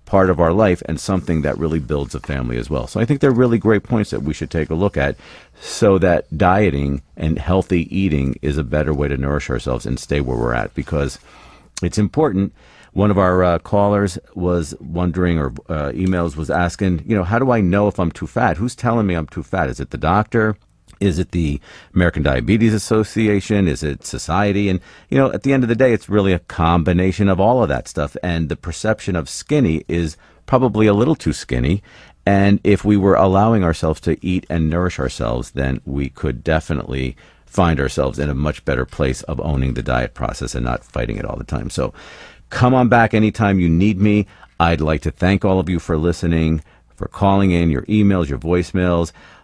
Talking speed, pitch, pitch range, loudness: 215 wpm, 90 Hz, 75-100 Hz, -18 LUFS